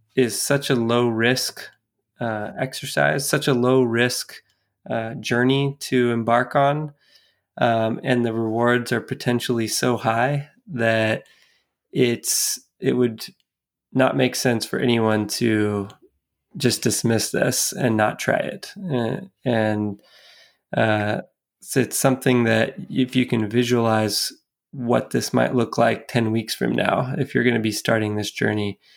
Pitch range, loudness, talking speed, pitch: 110-125 Hz, -21 LUFS, 140 wpm, 120 Hz